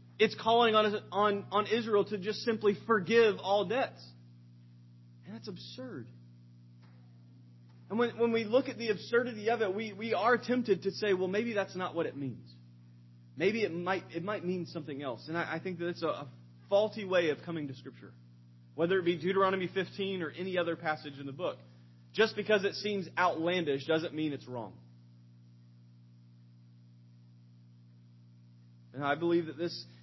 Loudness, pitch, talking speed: -32 LUFS, 160 Hz, 170 wpm